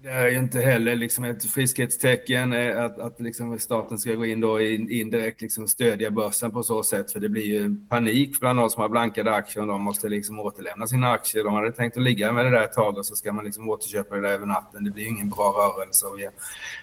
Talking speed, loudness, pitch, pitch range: 230 wpm, -24 LUFS, 115 Hz, 105-120 Hz